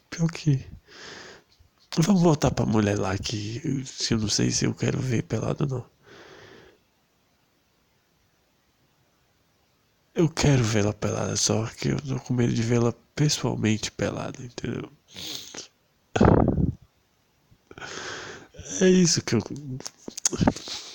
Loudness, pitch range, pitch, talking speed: -25 LUFS, 105-150 Hz, 125 Hz, 110 wpm